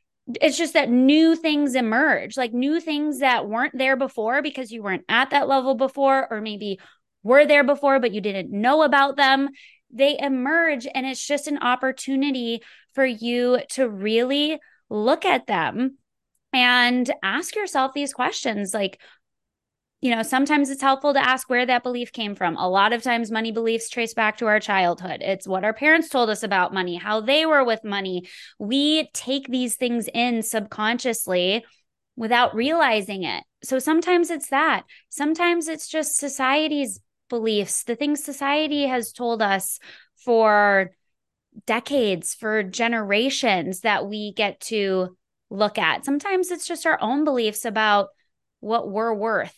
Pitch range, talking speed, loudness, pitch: 220-280 Hz, 160 wpm, -21 LUFS, 250 Hz